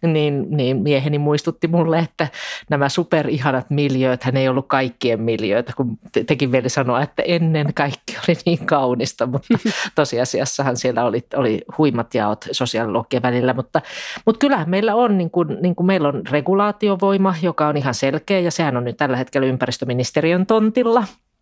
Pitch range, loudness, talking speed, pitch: 130-175 Hz, -19 LUFS, 160 wpm, 145 Hz